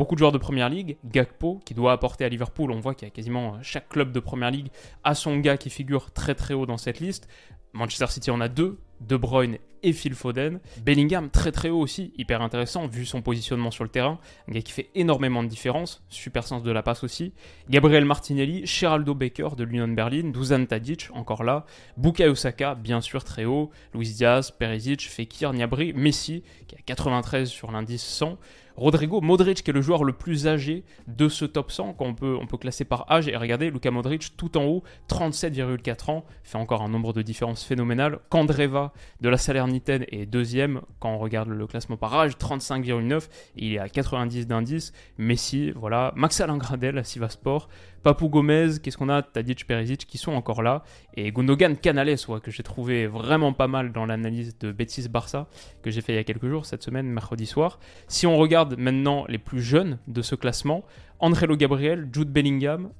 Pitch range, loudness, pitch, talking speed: 120-150 Hz, -25 LUFS, 130 Hz, 205 wpm